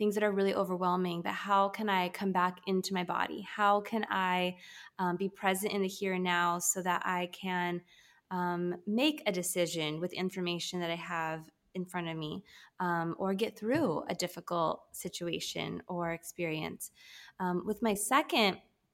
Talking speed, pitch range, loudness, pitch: 175 wpm, 175-195 Hz, -33 LUFS, 180 Hz